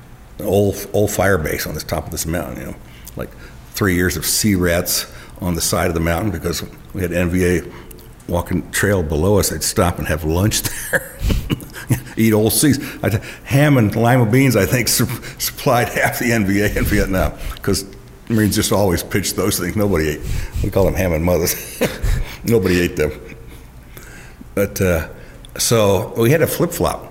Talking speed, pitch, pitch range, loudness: 180 wpm, 95 Hz, 85-105 Hz, -18 LUFS